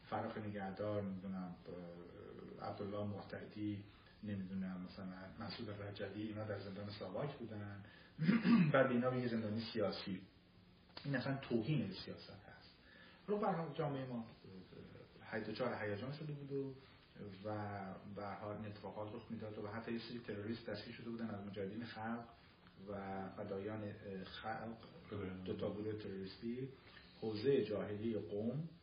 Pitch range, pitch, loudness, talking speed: 100-115 Hz, 105 Hz, -44 LUFS, 125 wpm